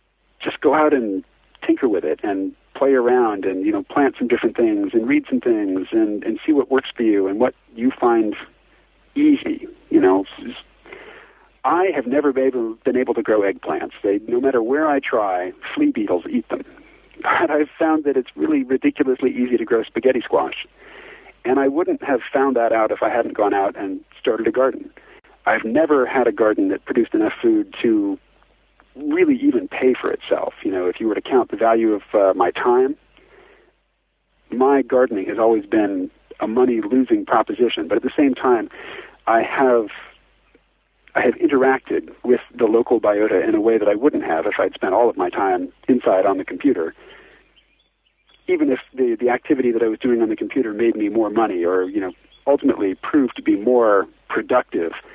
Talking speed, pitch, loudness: 195 wpm, 315 Hz, -19 LUFS